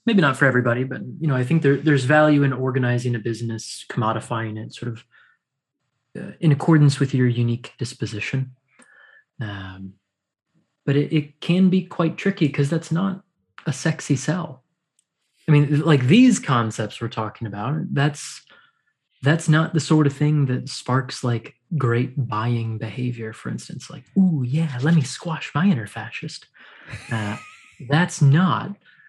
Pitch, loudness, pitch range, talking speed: 140 Hz, -21 LUFS, 120-160 Hz, 155 wpm